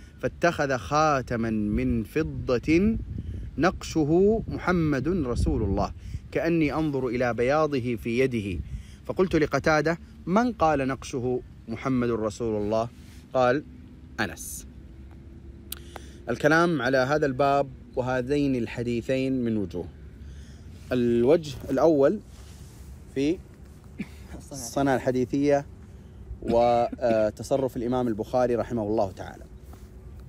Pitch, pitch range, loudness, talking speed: 120 Hz, 100-140 Hz, -26 LUFS, 85 wpm